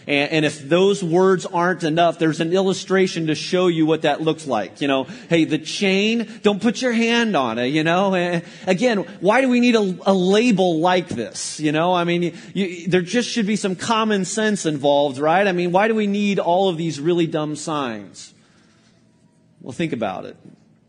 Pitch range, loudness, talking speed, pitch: 160-200 Hz, -19 LUFS, 200 wpm, 180 Hz